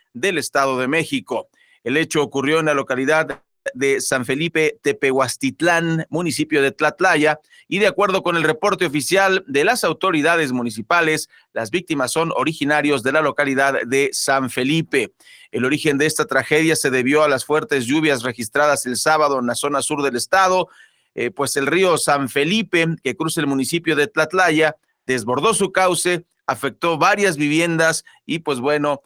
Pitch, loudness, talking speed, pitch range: 150 Hz, -18 LUFS, 165 wpm, 140-165 Hz